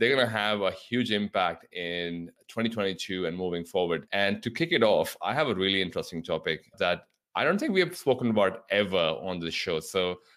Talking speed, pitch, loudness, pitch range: 210 wpm, 100 Hz, -28 LUFS, 90-115 Hz